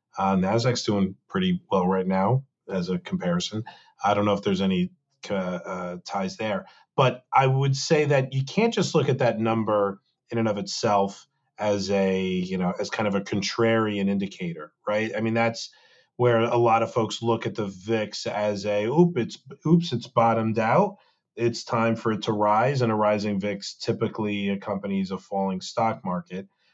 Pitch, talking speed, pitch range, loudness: 110 Hz, 185 wpm, 100-130 Hz, -25 LUFS